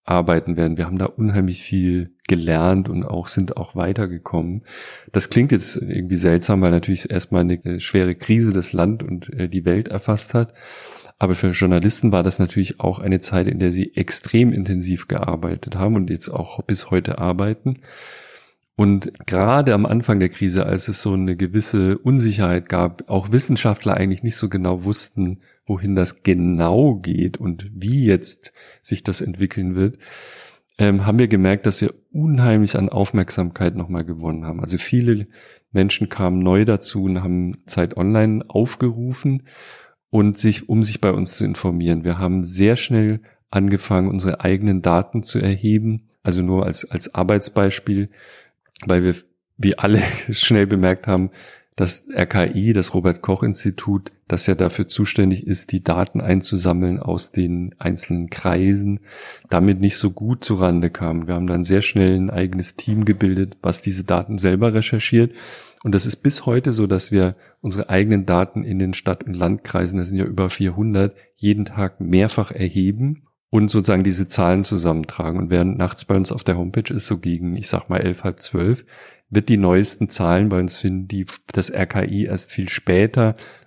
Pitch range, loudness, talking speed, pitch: 90-105 Hz, -19 LUFS, 170 wpm, 95 Hz